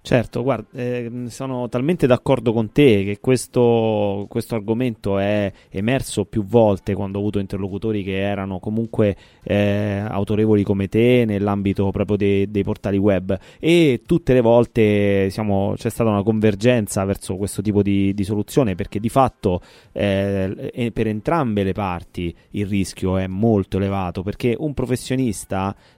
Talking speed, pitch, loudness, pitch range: 150 wpm, 105 Hz, -20 LUFS, 100-120 Hz